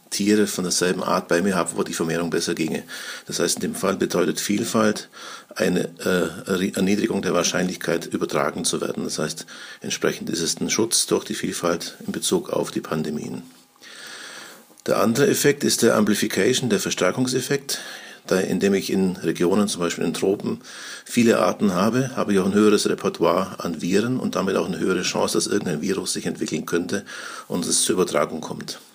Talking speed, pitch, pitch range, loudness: 180 wpm, 100 Hz, 90-105 Hz, -22 LUFS